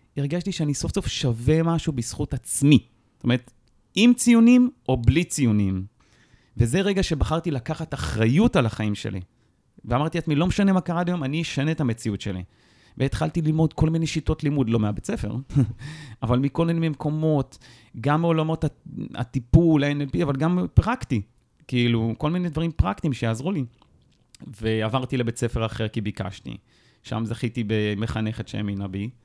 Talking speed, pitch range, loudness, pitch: 150 wpm, 115-155 Hz, -23 LUFS, 130 Hz